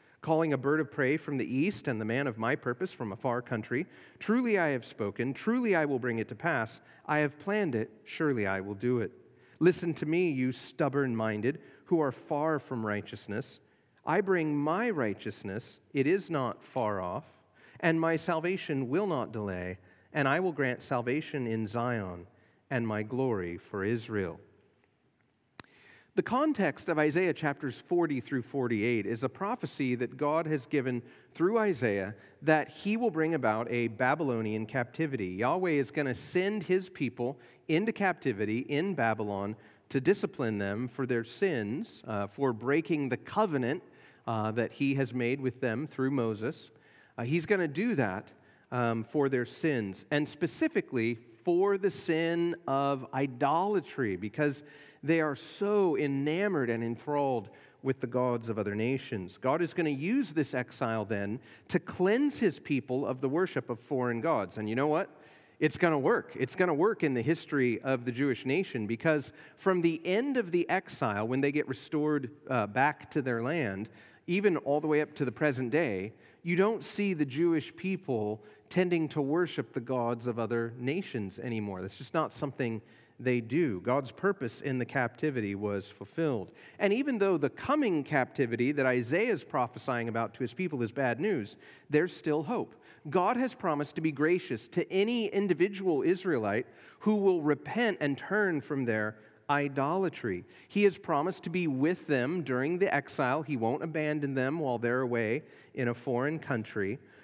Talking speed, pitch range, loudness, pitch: 175 wpm, 120-165 Hz, -31 LUFS, 140 Hz